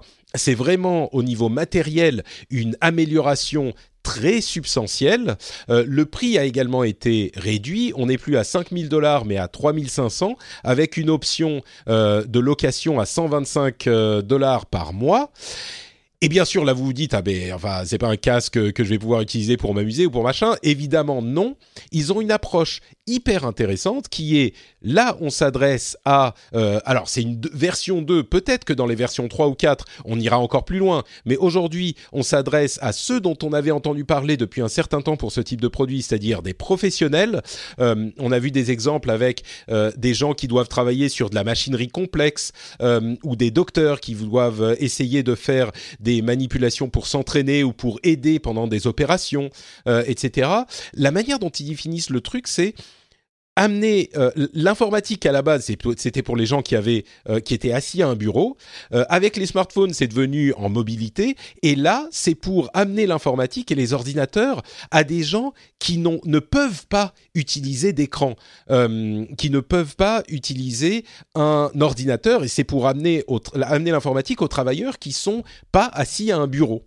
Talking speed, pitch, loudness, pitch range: 185 wpm, 140 Hz, -20 LUFS, 120-165 Hz